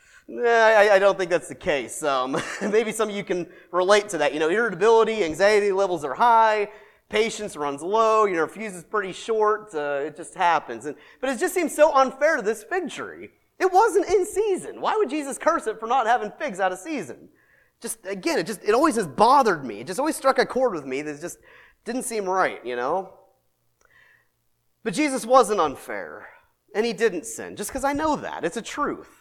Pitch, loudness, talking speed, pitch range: 220 Hz, -22 LUFS, 215 wpm, 190-270 Hz